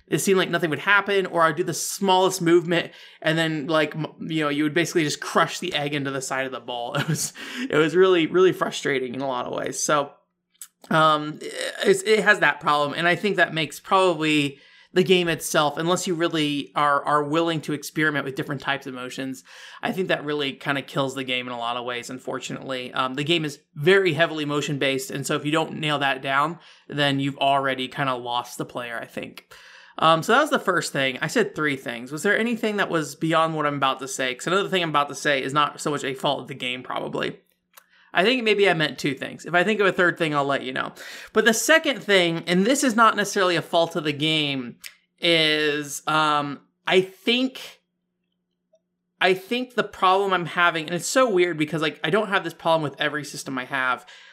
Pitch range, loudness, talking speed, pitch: 140-180 Hz, -22 LUFS, 230 wpm, 155 Hz